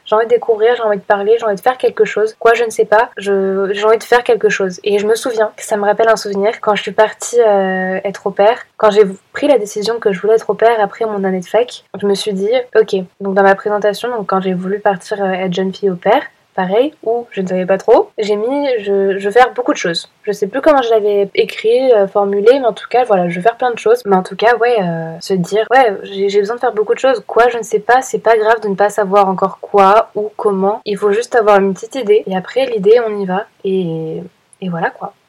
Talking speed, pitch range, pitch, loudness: 270 wpm, 200-230 Hz, 210 Hz, -14 LUFS